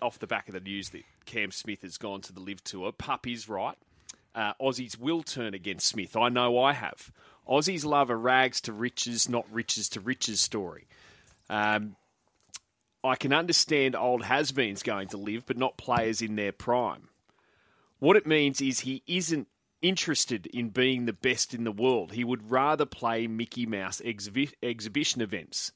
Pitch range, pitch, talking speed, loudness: 105-130 Hz, 120 Hz, 180 wpm, -29 LUFS